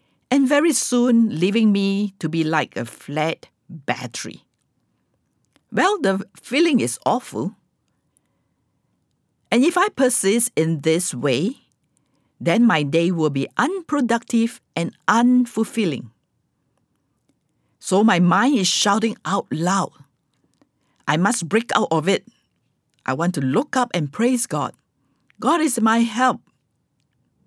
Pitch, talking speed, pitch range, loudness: 200 Hz, 120 wpm, 160-240 Hz, -20 LUFS